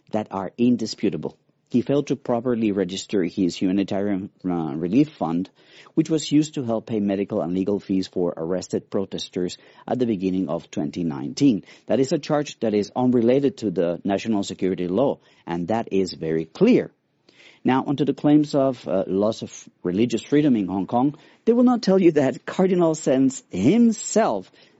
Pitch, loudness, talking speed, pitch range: 110 Hz, -22 LUFS, 170 wpm, 95-140 Hz